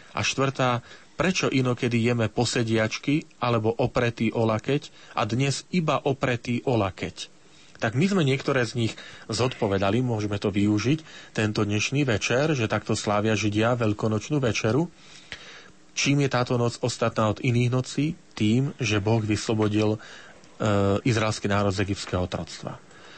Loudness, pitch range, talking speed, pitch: -25 LUFS, 110-135 Hz, 135 wpm, 120 Hz